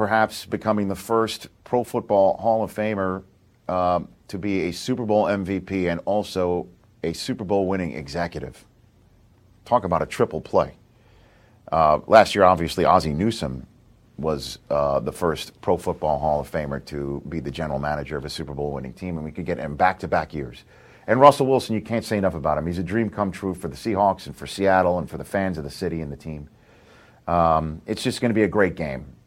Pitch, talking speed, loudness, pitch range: 95 Hz, 210 wpm, -23 LUFS, 80-110 Hz